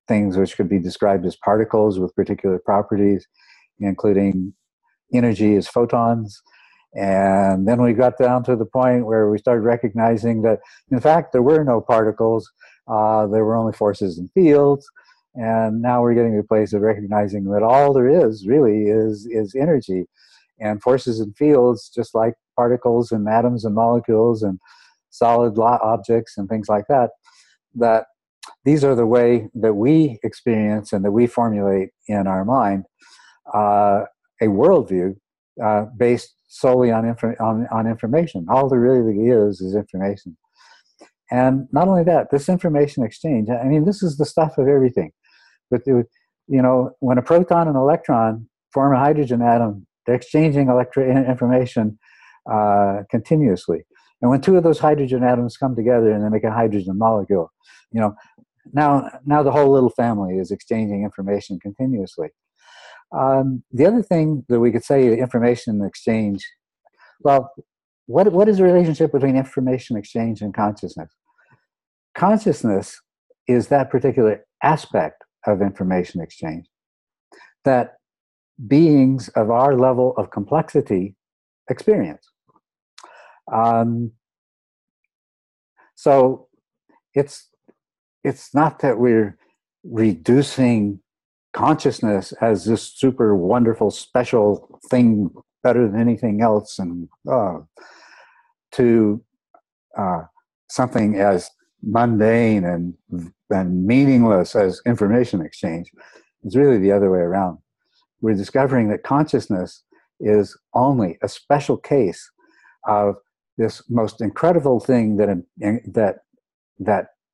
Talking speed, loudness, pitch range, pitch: 130 wpm, -18 LUFS, 105-130 Hz, 115 Hz